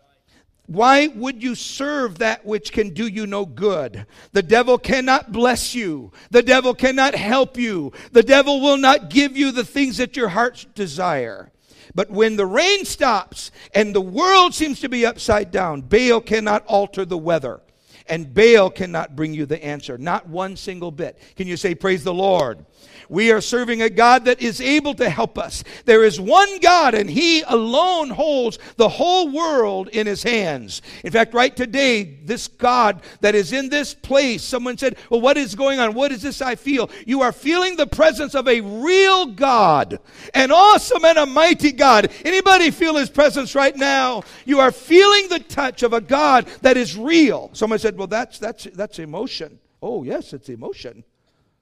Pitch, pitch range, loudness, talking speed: 245 Hz, 205-280 Hz, -17 LUFS, 185 wpm